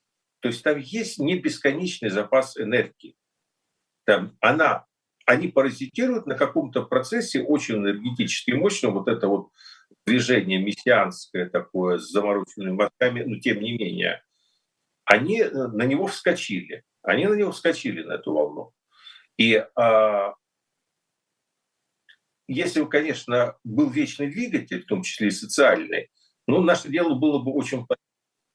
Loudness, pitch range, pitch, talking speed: -23 LUFS, 110-180 Hz, 135 Hz, 130 wpm